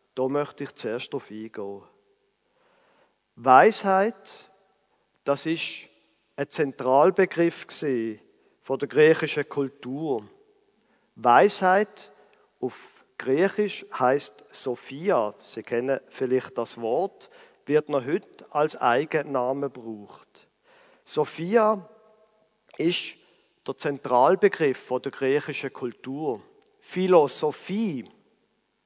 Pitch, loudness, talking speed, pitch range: 150 Hz, -25 LUFS, 85 wpm, 130-210 Hz